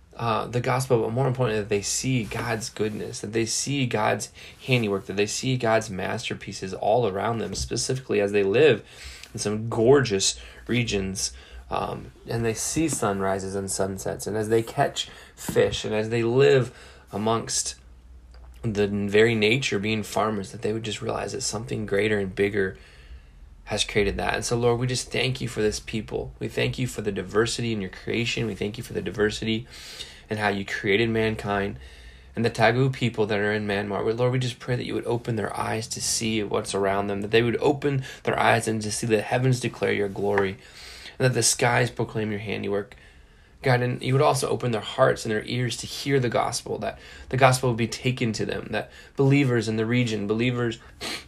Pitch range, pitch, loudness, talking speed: 100-120 Hz, 110 Hz, -25 LUFS, 200 wpm